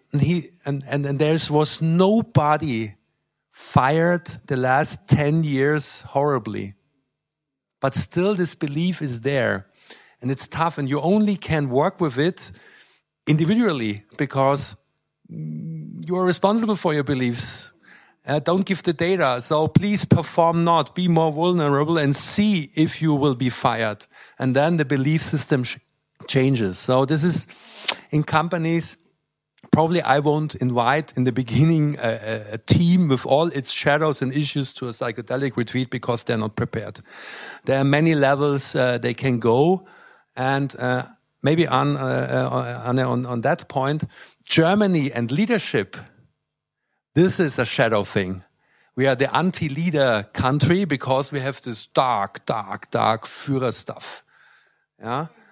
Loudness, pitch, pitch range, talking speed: -21 LUFS, 145 Hz, 125-160 Hz, 145 wpm